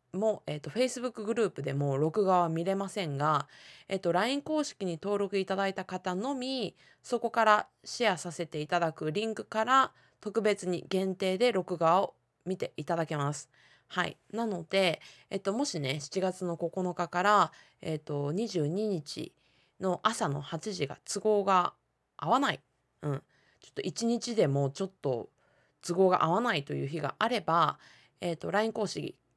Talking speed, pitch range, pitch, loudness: 305 characters per minute, 160-210 Hz, 185 Hz, -31 LUFS